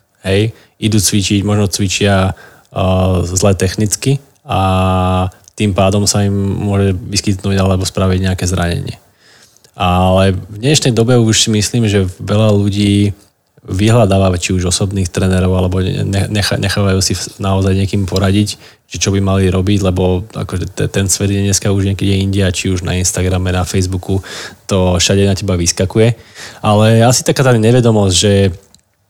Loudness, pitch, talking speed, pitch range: -13 LUFS, 100 Hz, 150 wpm, 95-105 Hz